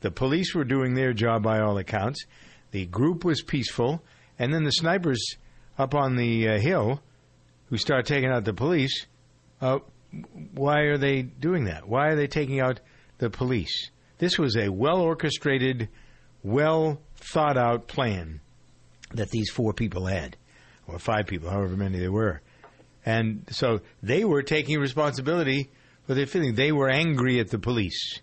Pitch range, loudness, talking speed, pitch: 110-145 Hz, -26 LUFS, 155 wpm, 130 Hz